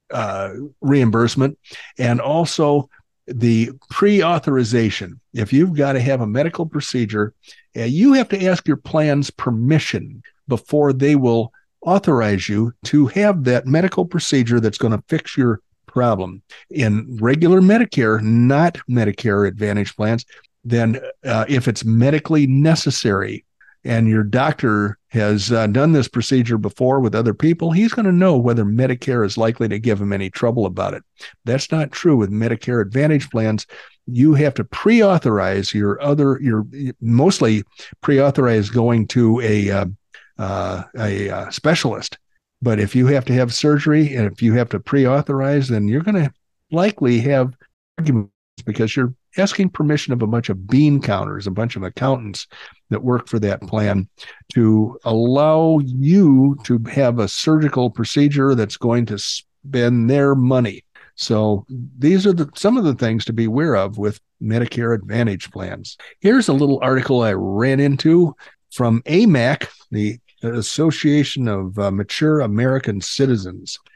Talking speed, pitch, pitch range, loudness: 155 wpm, 125 Hz, 110-145 Hz, -17 LUFS